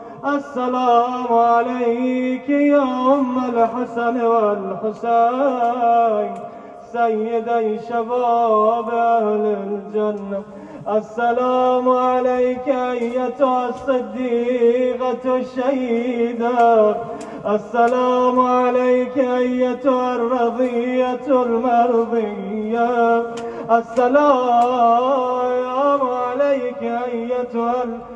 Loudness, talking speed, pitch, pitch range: -18 LUFS, 50 wpm, 240 Hz, 230-250 Hz